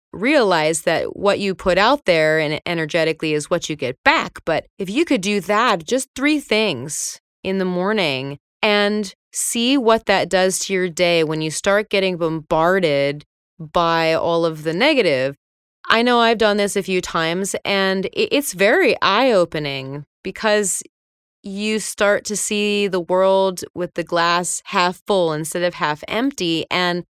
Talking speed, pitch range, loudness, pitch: 165 wpm, 165-205 Hz, -18 LUFS, 185 Hz